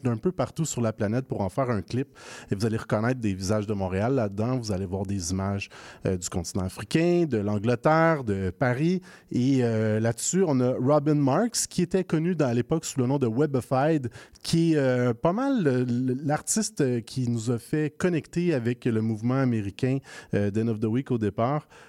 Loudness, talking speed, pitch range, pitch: -26 LUFS, 200 wpm, 110-150 Hz, 125 Hz